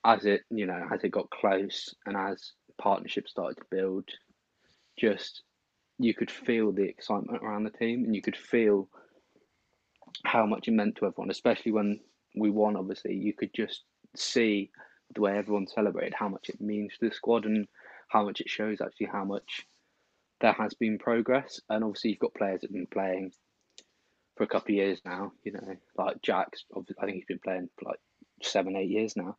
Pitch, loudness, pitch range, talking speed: 105 Hz, -31 LUFS, 100-115 Hz, 195 wpm